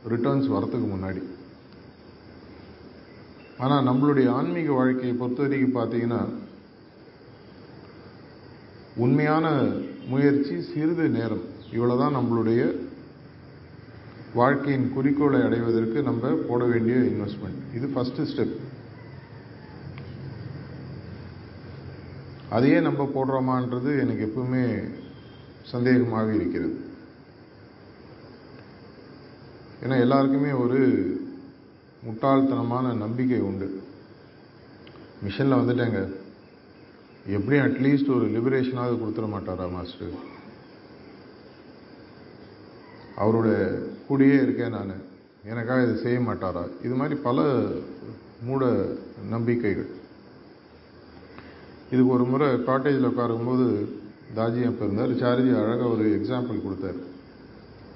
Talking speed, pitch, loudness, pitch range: 75 wpm, 125 Hz, -25 LUFS, 110-135 Hz